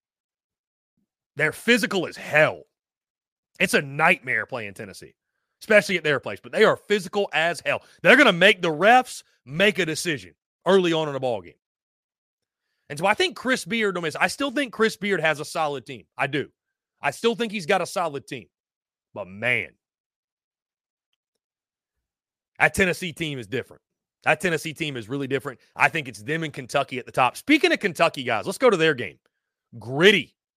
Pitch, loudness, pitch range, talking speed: 165 Hz, -22 LUFS, 140-200 Hz, 180 wpm